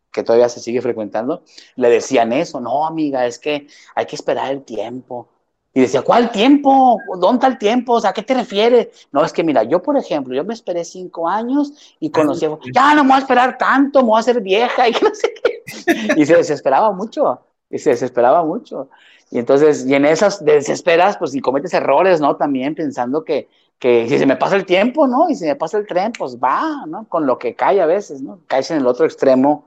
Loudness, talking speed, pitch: -16 LUFS, 225 wpm, 225 Hz